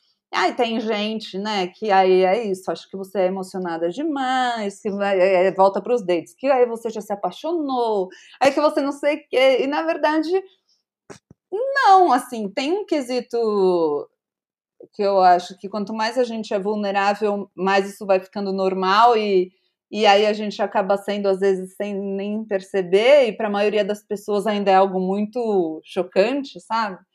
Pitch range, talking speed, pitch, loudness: 190-245 Hz, 175 wpm, 210 Hz, -20 LUFS